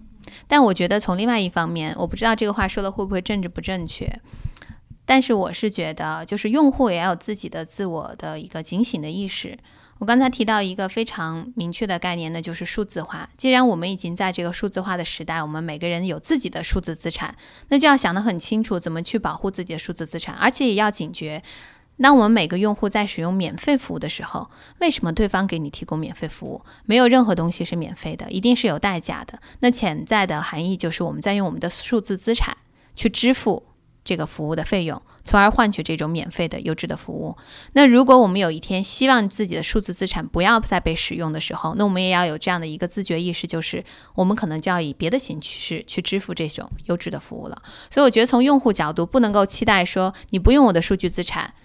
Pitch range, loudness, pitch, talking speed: 170-225 Hz, -20 LUFS, 190 Hz, 355 characters per minute